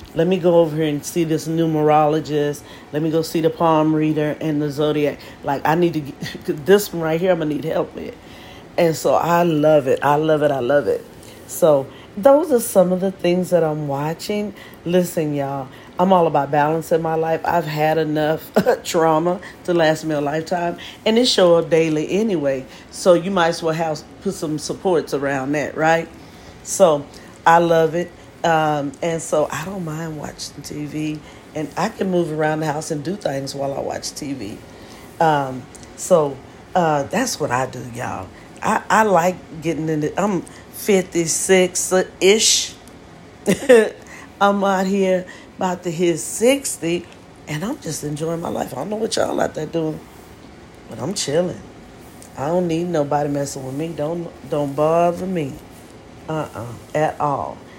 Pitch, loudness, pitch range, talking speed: 160 Hz, -19 LUFS, 150-180 Hz, 180 wpm